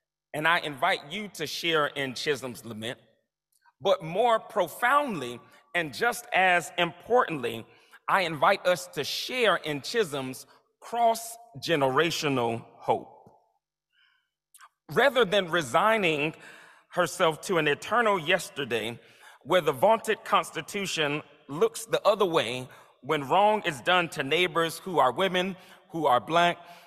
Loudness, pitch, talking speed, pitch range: -26 LUFS, 170 Hz, 120 wpm, 150-195 Hz